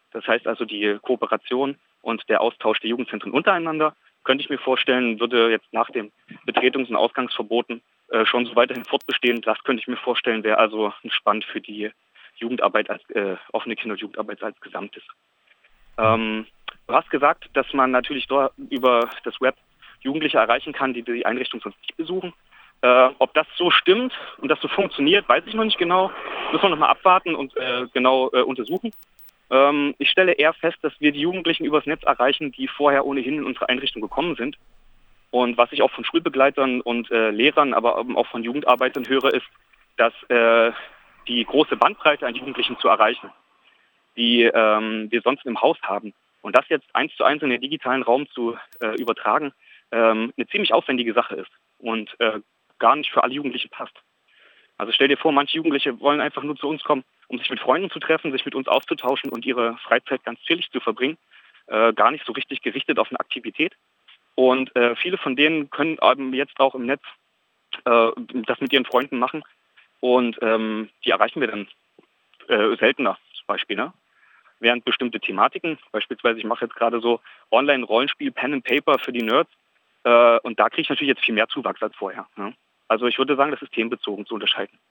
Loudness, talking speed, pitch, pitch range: -21 LUFS, 190 wpm, 130 Hz, 120-150 Hz